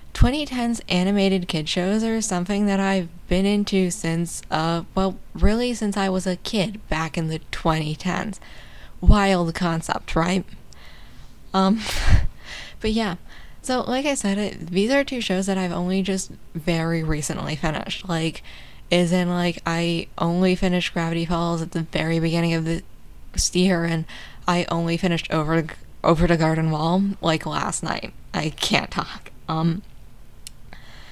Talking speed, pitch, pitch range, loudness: 150 wpm, 175 Hz, 165-195 Hz, -23 LUFS